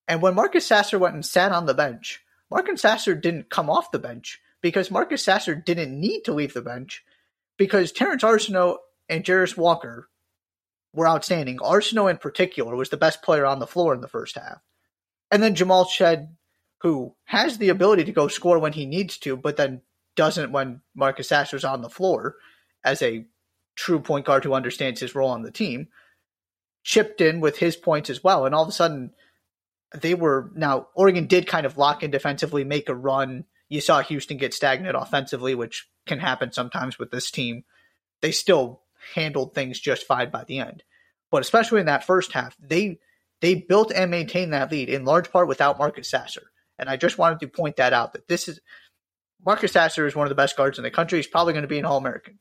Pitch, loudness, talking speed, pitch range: 155 Hz, -22 LUFS, 205 wpm, 135-180 Hz